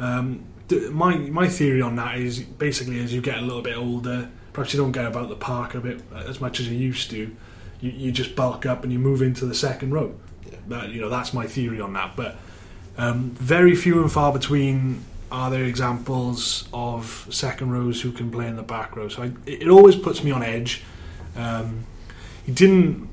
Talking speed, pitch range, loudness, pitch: 215 wpm, 115-130 Hz, -22 LUFS, 125 Hz